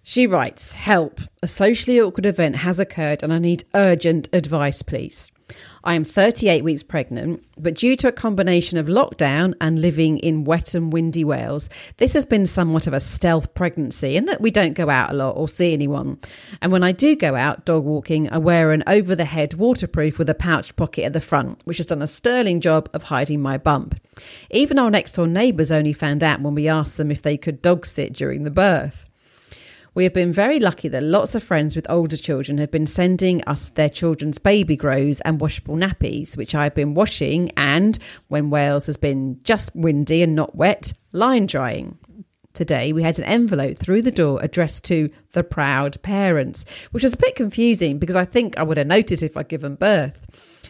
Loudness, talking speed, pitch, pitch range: -19 LUFS, 205 wpm, 165 Hz, 150-185 Hz